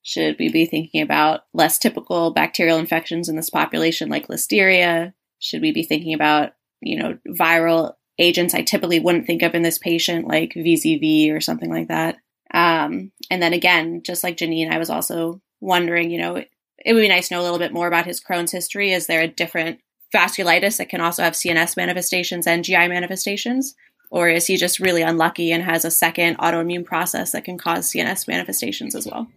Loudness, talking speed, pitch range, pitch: -19 LUFS, 200 wpm, 165-180 Hz, 170 Hz